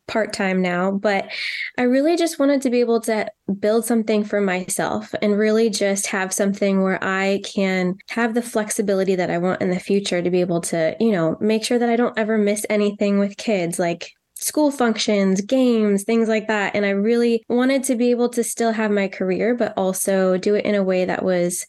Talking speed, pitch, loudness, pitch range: 215 wpm, 210 Hz, -20 LUFS, 190-230 Hz